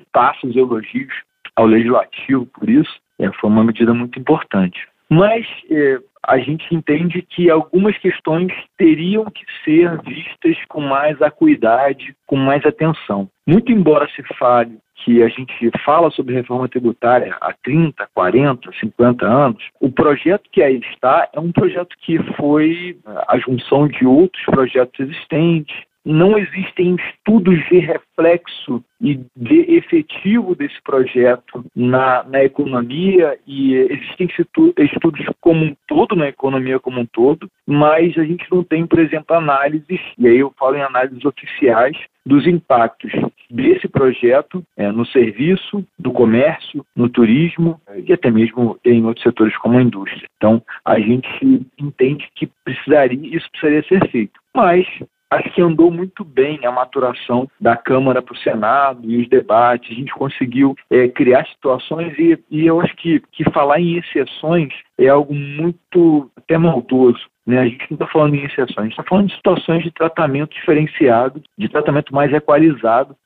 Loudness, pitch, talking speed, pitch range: -15 LUFS, 150 Hz, 155 wpm, 125-170 Hz